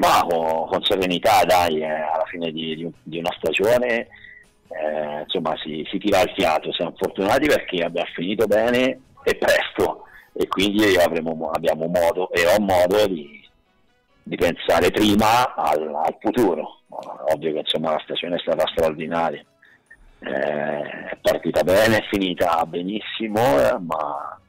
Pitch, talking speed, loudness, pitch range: 85 Hz, 145 wpm, -21 LUFS, 80-90 Hz